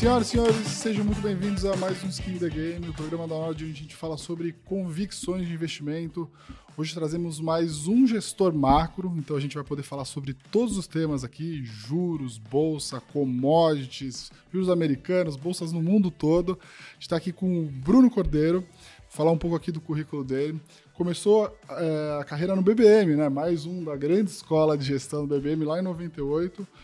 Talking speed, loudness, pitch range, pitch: 185 wpm, -26 LUFS, 150-185 Hz, 165 Hz